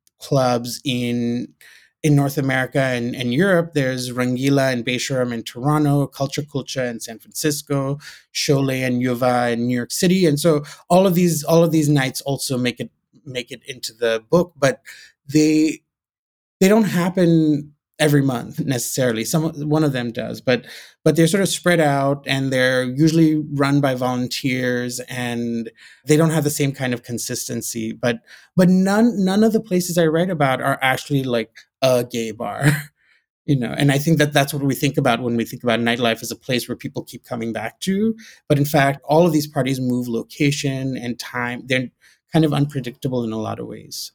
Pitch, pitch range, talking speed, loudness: 135 Hz, 125-155 Hz, 190 wpm, -20 LUFS